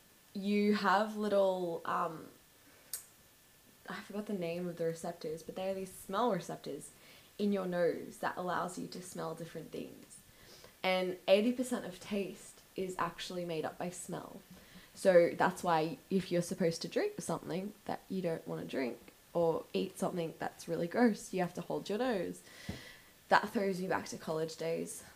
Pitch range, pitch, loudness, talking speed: 170-200 Hz, 185 Hz, -36 LUFS, 170 wpm